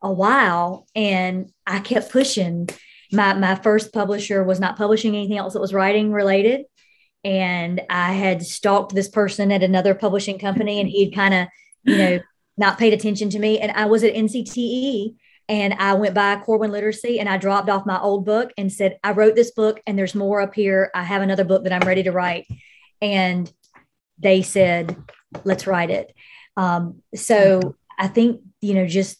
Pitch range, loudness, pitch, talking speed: 190-210 Hz, -19 LUFS, 200 Hz, 185 wpm